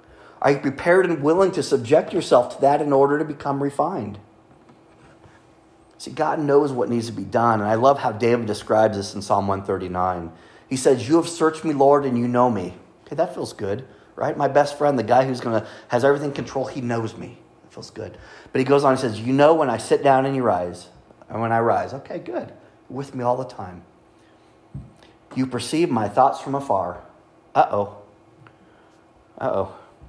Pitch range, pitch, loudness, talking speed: 110-140 Hz, 125 Hz, -21 LUFS, 200 wpm